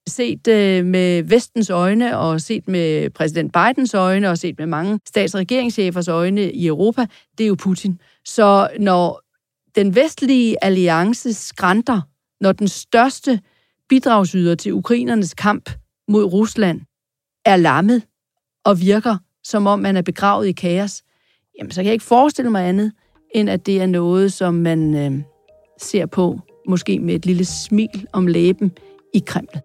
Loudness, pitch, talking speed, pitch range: -17 LUFS, 195 Hz, 155 wpm, 175-220 Hz